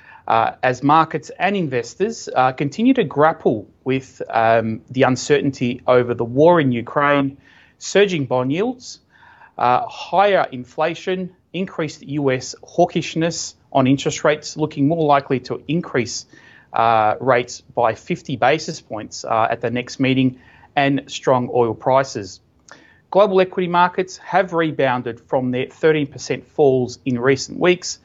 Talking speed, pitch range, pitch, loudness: 135 wpm, 125-165 Hz, 140 Hz, -19 LUFS